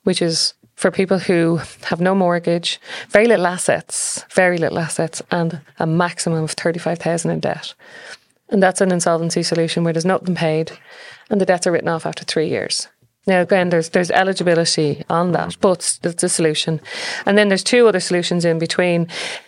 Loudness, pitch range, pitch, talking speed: -18 LUFS, 165-185 Hz, 175 Hz, 180 wpm